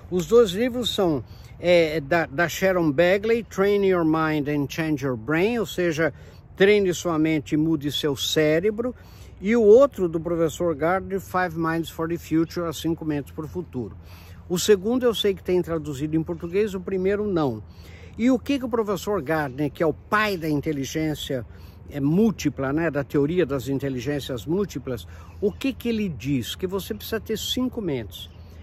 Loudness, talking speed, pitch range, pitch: -23 LUFS, 180 wpm, 145-195 Hz, 165 Hz